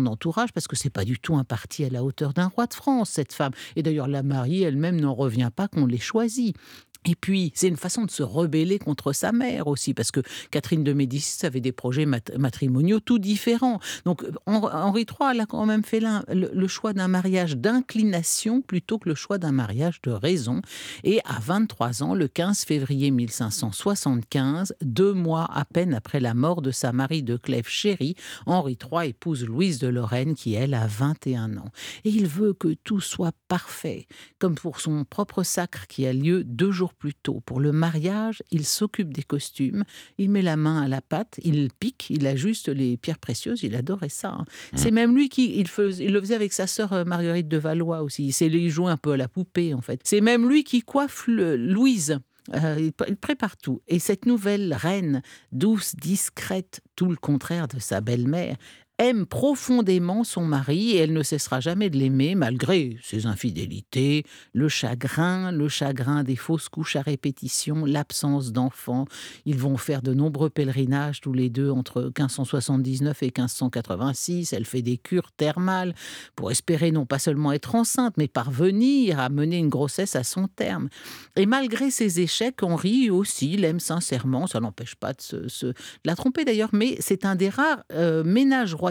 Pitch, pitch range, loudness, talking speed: 160 Hz, 135-195 Hz, -25 LUFS, 190 wpm